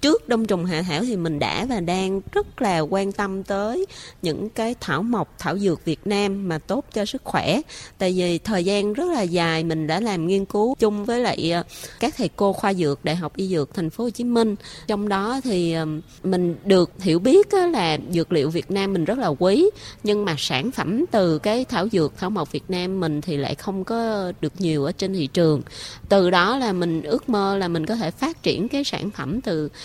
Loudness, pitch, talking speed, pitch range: -22 LUFS, 195 Hz, 225 wpm, 165-220 Hz